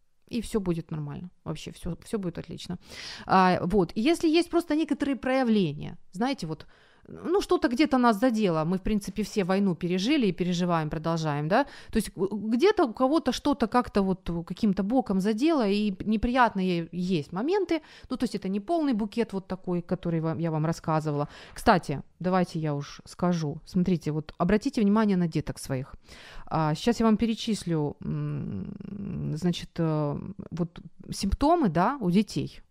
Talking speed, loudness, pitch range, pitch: 150 wpm, -27 LUFS, 170-235 Hz, 190 Hz